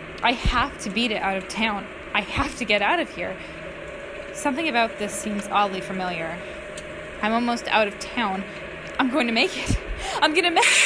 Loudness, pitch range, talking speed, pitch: -23 LUFS, 195-240 Hz, 195 wpm, 210 Hz